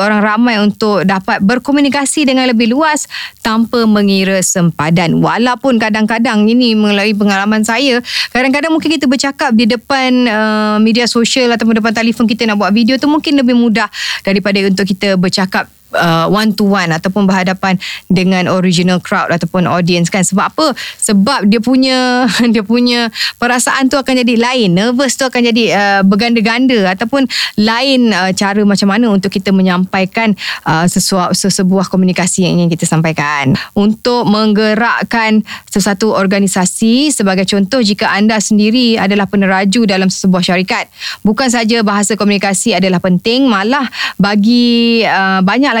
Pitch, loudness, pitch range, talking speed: 215 Hz, -11 LUFS, 195-240 Hz, 145 wpm